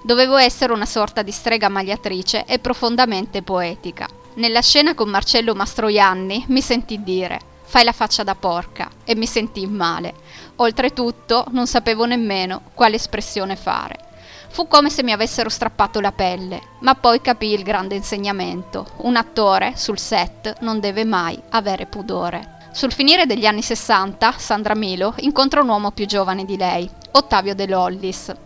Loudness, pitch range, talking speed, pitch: -18 LUFS, 195-240 Hz, 155 wpm, 220 Hz